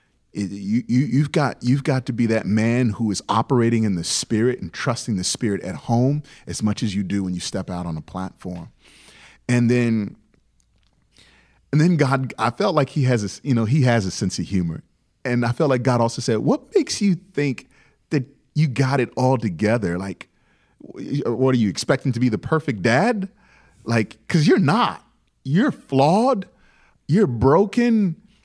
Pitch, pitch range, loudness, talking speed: 120 Hz, 105-140 Hz, -21 LUFS, 185 wpm